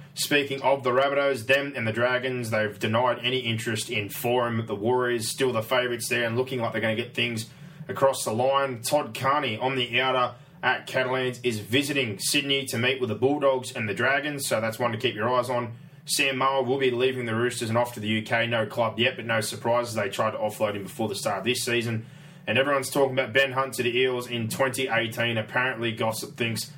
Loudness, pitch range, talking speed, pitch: -25 LUFS, 115-135 Hz, 225 wpm, 125 Hz